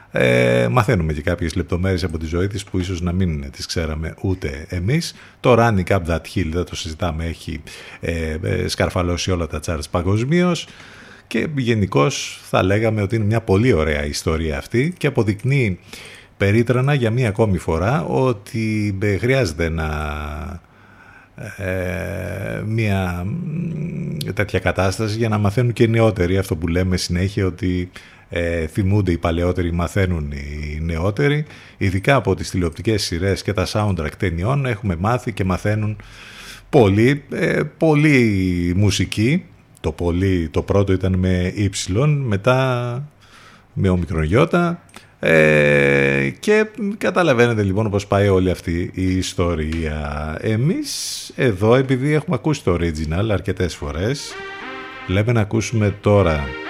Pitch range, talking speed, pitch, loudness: 85-115 Hz, 135 wpm, 95 Hz, -19 LUFS